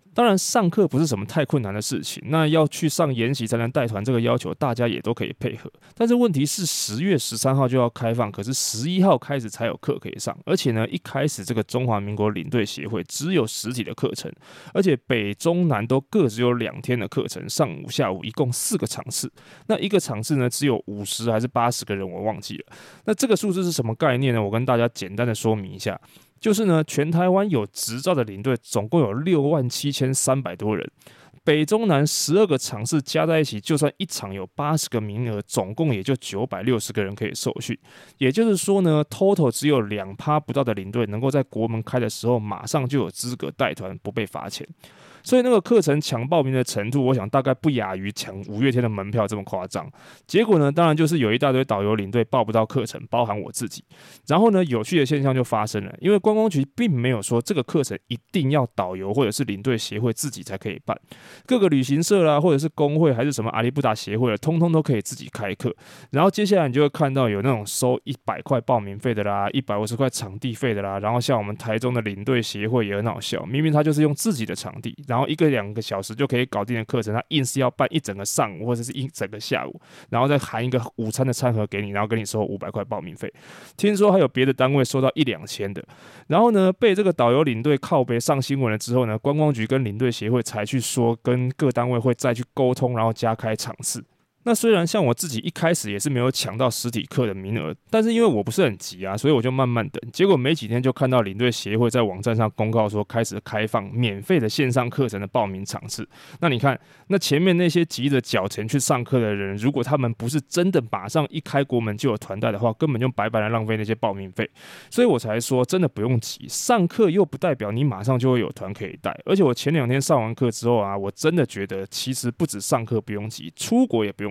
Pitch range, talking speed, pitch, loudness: 110-150 Hz, 355 characters per minute, 125 Hz, -22 LUFS